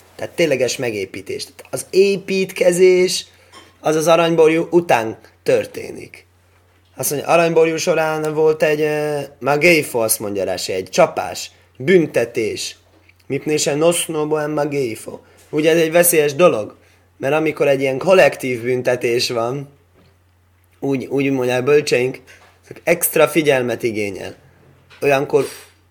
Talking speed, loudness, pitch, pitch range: 115 wpm, -17 LUFS, 150 Hz, 125-170 Hz